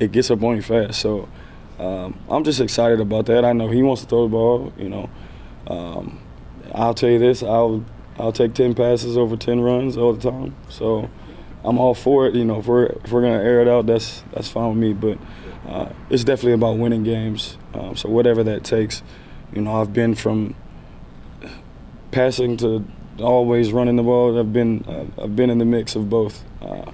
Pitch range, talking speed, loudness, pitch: 110-120 Hz, 205 wpm, -19 LUFS, 115 Hz